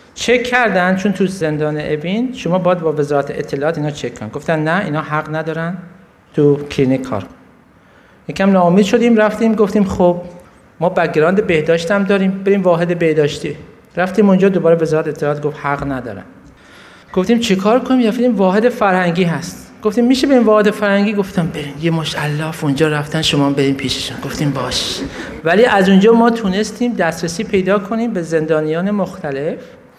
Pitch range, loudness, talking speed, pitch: 150-205 Hz, -15 LUFS, 160 wpm, 175 Hz